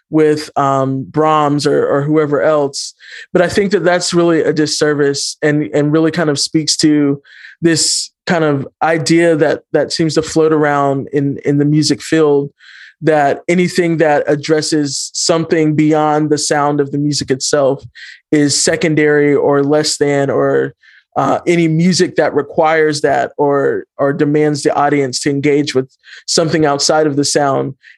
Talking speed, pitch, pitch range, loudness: 160 wpm, 150 Hz, 145-160 Hz, -13 LUFS